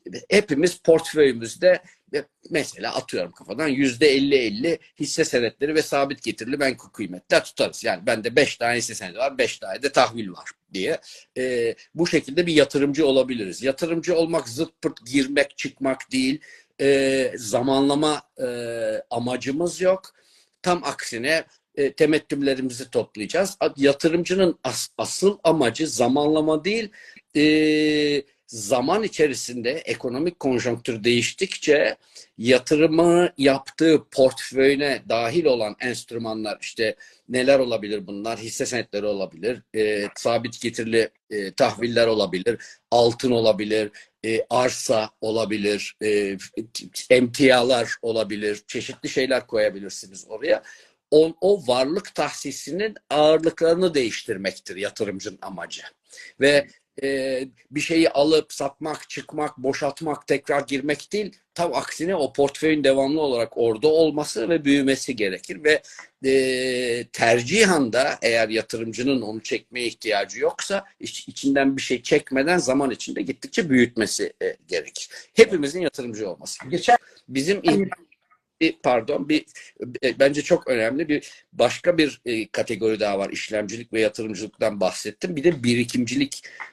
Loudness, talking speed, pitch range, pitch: -22 LUFS, 115 wpm, 120-165 Hz, 140 Hz